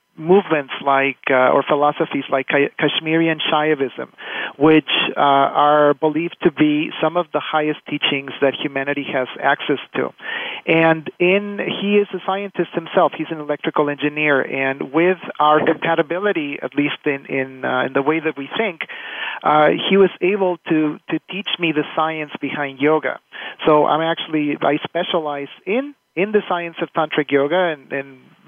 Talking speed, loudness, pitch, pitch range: 160 wpm, -18 LUFS, 155 Hz, 145-175 Hz